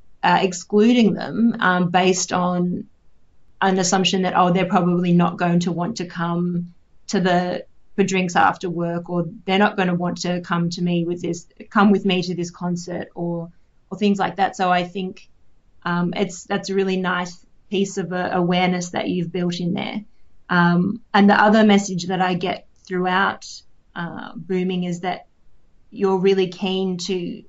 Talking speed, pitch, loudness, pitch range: 180 wpm, 180 Hz, -20 LUFS, 175-195 Hz